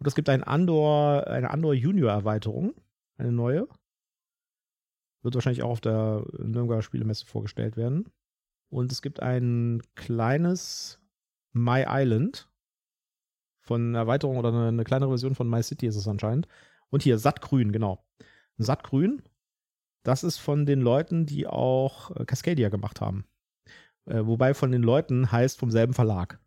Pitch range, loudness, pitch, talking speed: 115-145 Hz, -26 LUFS, 125 Hz, 140 wpm